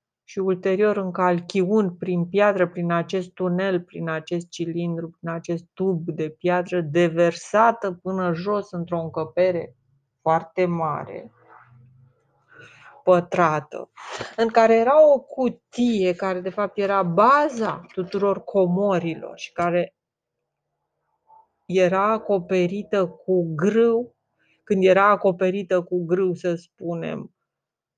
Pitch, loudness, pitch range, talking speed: 180 Hz, -22 LUFS, 170-200 Hz, 105 wpm